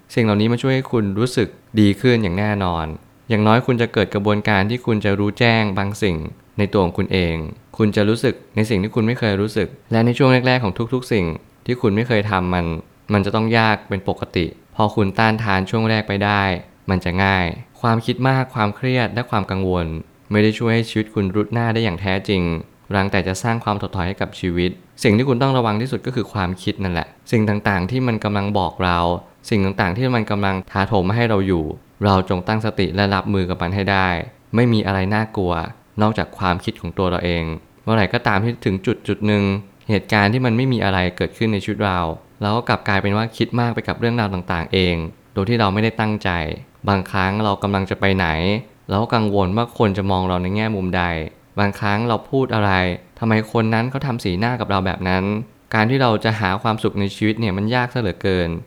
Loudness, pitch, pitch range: -19 LUFS, 105 Hz, 95-115 Hz